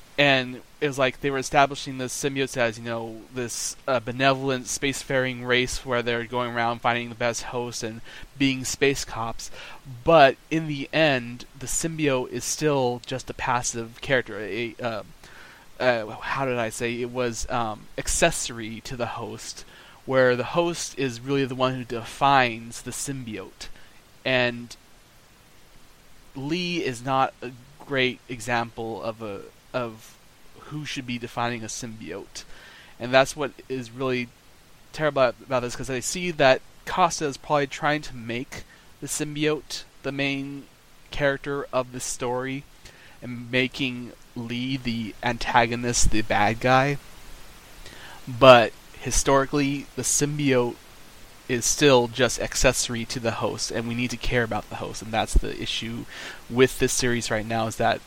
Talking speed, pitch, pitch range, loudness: 150 wpm, 125 Hz, 120-135 Hz, -24 LUFS